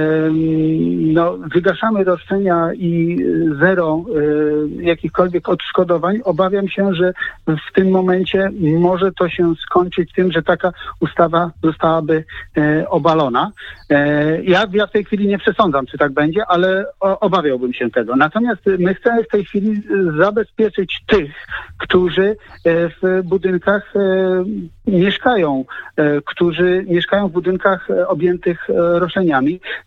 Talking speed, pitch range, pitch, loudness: 110 wpm, 165-195 Hz, 180 Hz, -16 LUFS